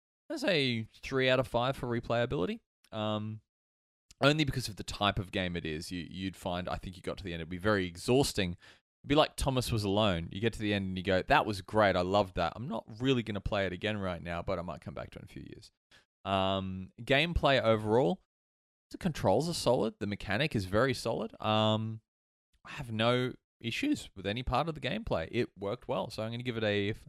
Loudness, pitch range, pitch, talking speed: -32 LUFS, 95-120 Hz, 105 Hz, 235 wpm